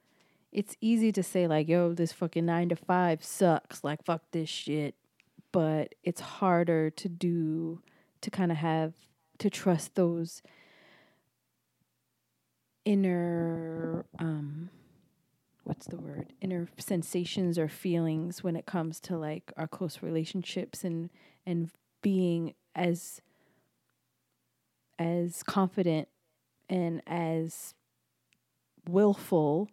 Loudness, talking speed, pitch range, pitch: -31 LUFS, 110 wpm, 160-180 Hz, 170 Hz